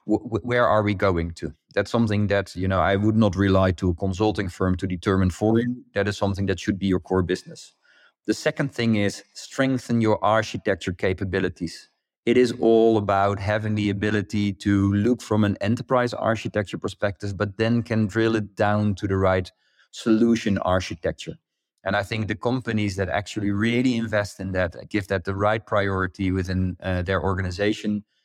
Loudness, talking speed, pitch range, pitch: -23 LUFS, 180 wpm, 95-110 Hz, 105 Hz